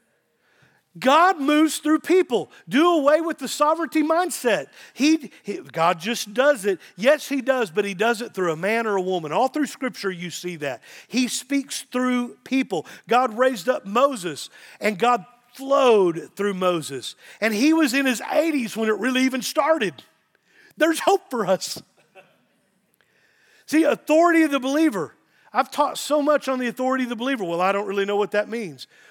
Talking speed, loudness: 175 wpm, -22 LUFS